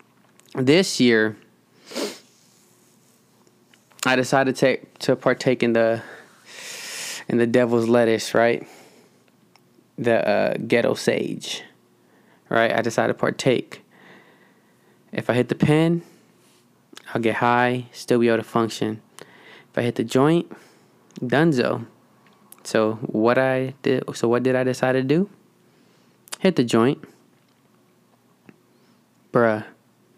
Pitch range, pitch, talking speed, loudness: 115-135 Hz, 125 Hz, 115 wpm, -21 LUFS